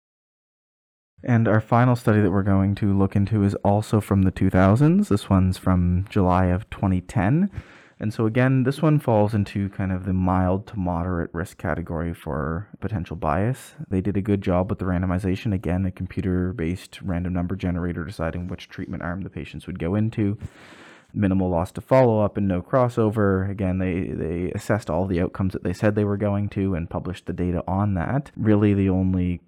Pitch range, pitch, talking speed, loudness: 90-105 Hz, 95 Hz, 190 wpm, -23 LUFS